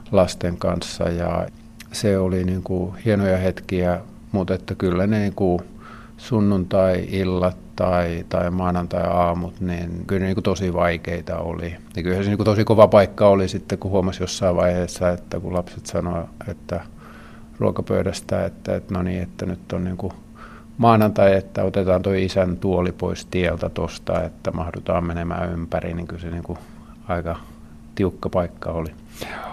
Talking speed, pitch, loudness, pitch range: 160 wpm, 90 Hz, -22 LUFS, 85-100 Hz